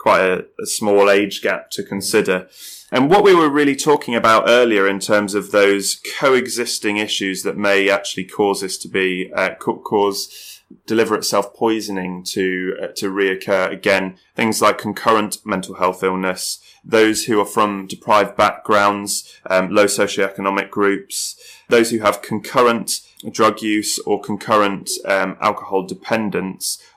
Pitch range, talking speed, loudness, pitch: 95-105 Hz, 145 wpm, -17 LUFS, 100 Hz